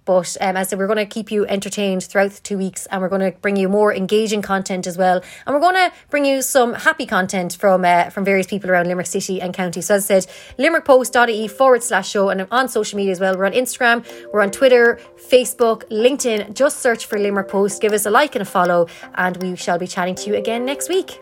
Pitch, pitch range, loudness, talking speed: 205 Hz, 190-240 Hz, -17 LUFS, 255 wpm